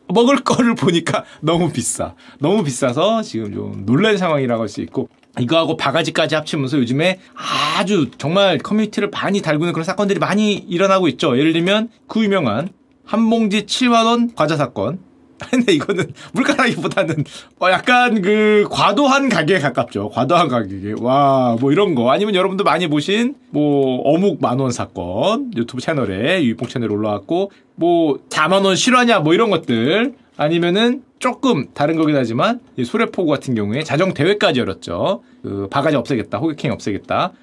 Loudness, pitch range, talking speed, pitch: -17 LUFS, 135-220 Hz, 355 characters per minute, 175 Hz